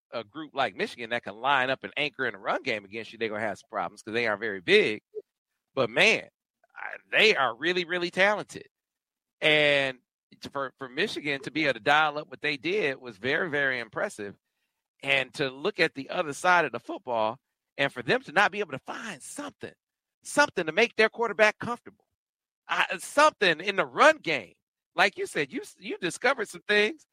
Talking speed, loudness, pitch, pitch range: 205 wpm, -26 LUFS, 155 Hz, 135-215 Hz